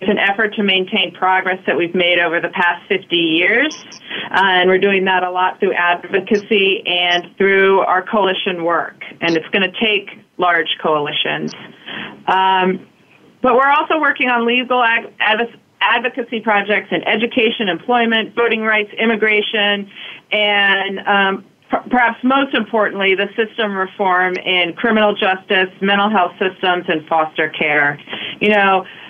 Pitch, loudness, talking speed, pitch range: 195 Hz, -15 LUFS, 145 wpm, 180-220 Hz